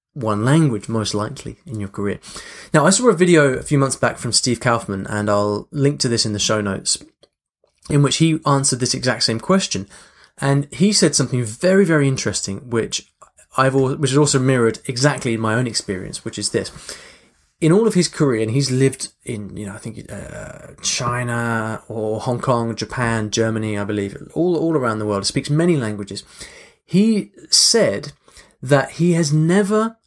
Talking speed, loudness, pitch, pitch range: 185 wpm, -18 LUFS, 130 Hz, 110-150 Hz